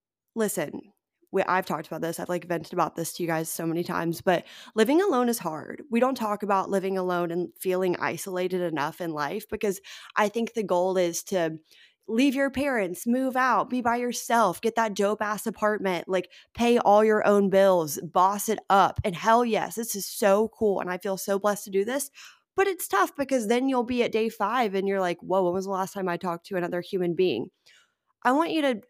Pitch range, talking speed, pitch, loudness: 180-230 Hz, 220 wpm, 195 Hz, -26 LUFS